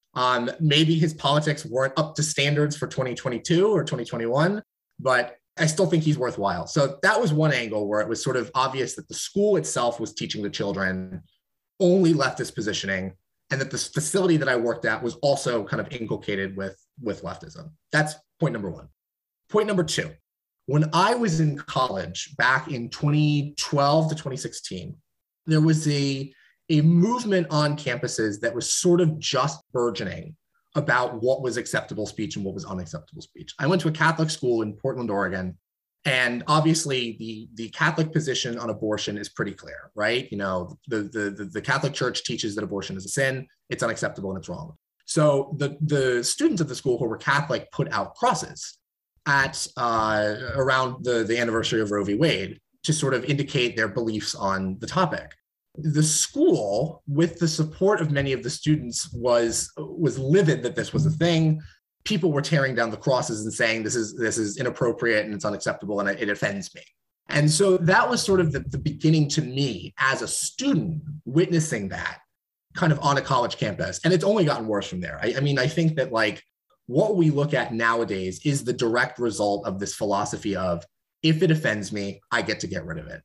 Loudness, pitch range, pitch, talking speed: -24 LUFS, 115-160 Hz, 140 Hz, 190 wpm